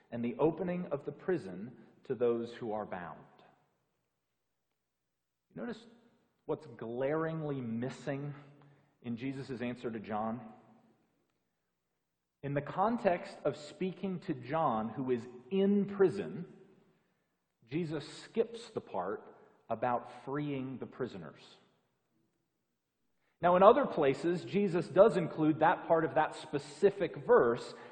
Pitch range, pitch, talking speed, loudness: 120-185 Hz, 145 Hz, 110 wpm, -33 LUFS